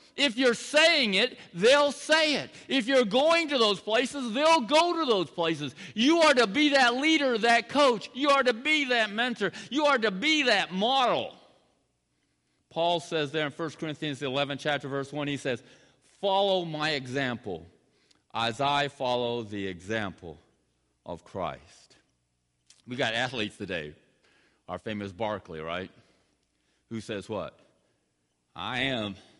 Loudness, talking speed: -26 LUFS, 150 wpm